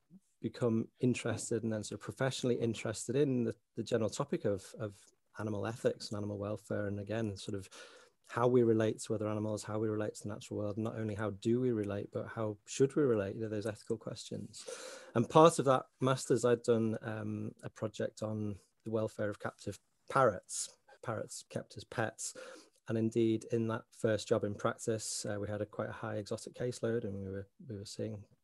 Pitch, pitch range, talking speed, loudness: 110 Hz, 105-120 Hz, 205 wpm, -36 LUFS